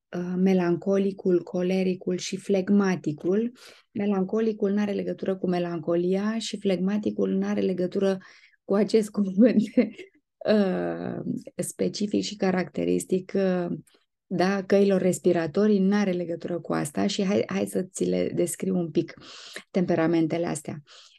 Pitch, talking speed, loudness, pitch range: 185 Hz, 110 wpm, -26 LUFS, 170-200 Hz